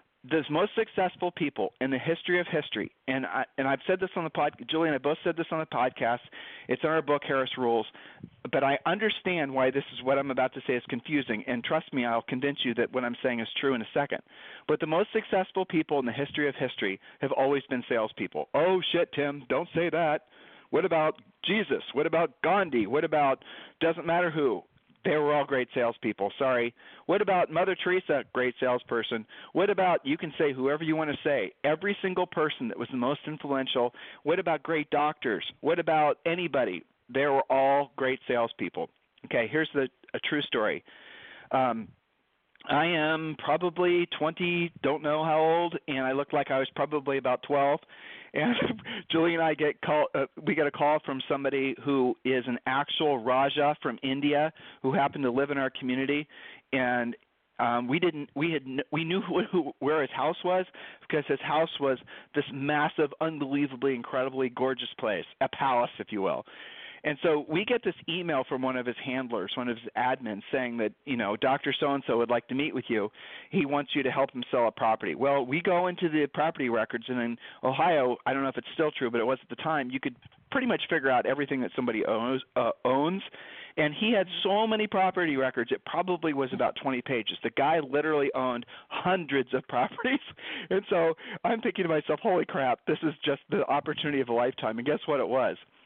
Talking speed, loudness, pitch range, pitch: 205 wpm, -29 LUFS, 130-165 Hz, 145 Hz